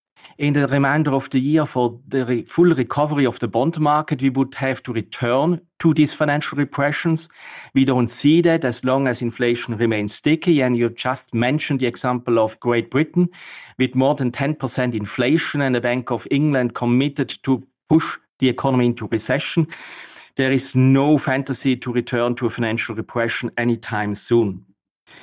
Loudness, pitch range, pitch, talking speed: -19 LUFS, 120-145 Hz, 130 Hz, 170 wpm